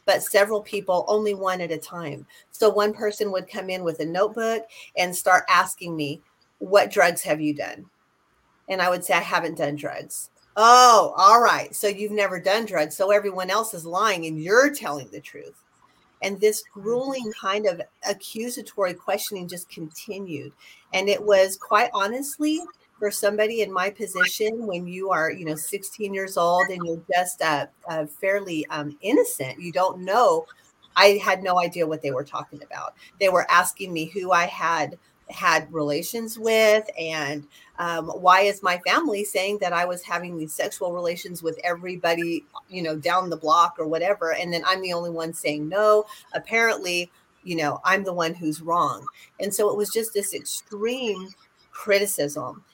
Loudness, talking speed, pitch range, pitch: -23 LUFS, 175 wpm, 170-210 Hz, 185 Hz